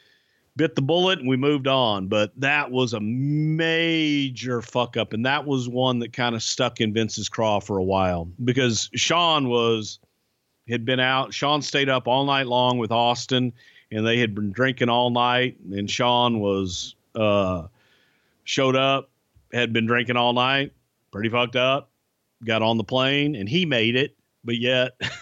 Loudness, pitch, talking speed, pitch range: -22 LUFS, 125 Hz, 175 wpm, 115-135 Hz